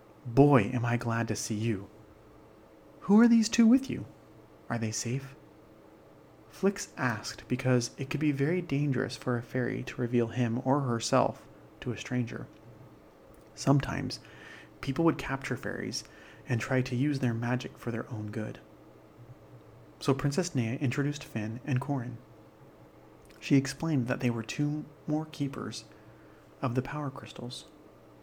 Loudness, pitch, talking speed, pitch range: -30 LUFS, 125 Hz, 145 wpm, 115-140 Hz